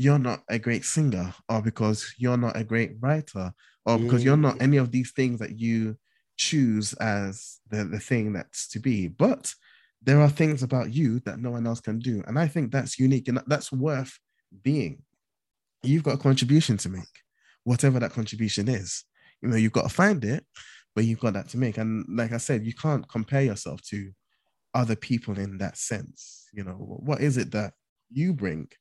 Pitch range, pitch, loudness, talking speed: 110-135 Hz, 120 Hz, -26 LUFS, 200 wpm